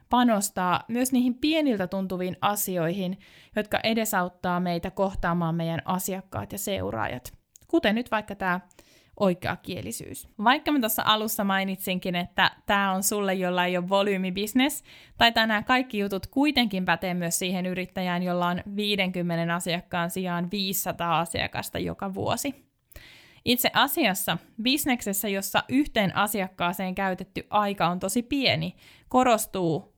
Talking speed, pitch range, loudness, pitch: 125 wpm, 180-220 Hz, -26 LUFS, 190 Hz